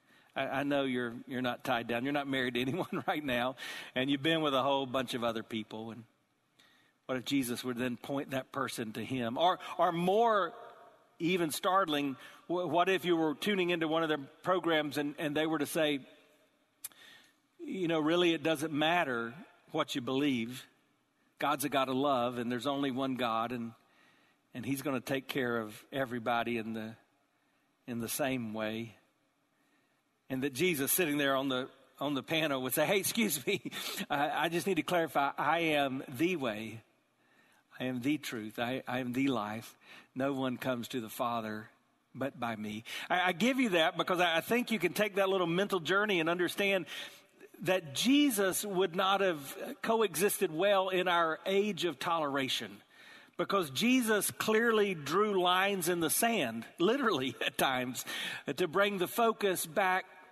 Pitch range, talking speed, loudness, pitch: 130-185 Hz, 175 wpm, -32 LUFS, 145 Hz